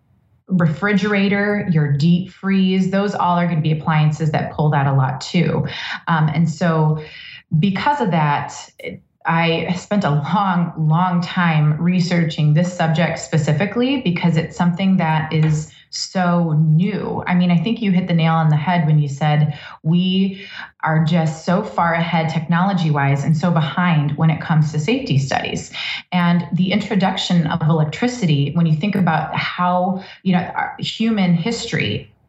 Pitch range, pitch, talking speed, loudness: 155-185 Hz, 170 Hz, 160 wpm, -18 LUFS